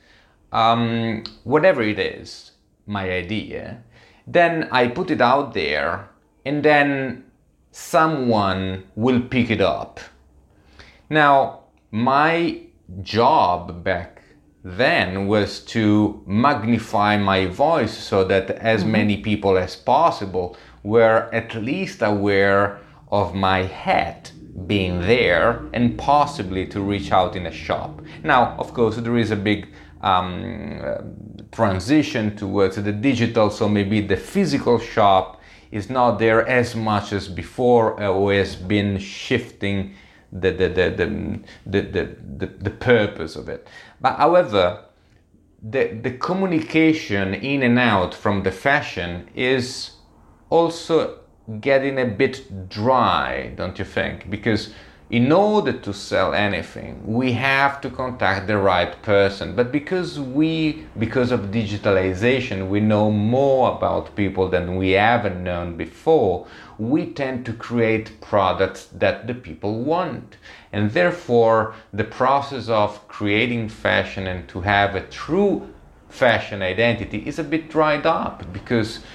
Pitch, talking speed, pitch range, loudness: 110 Hz, 130 wpm, 100-125 Hz, -20 LUFS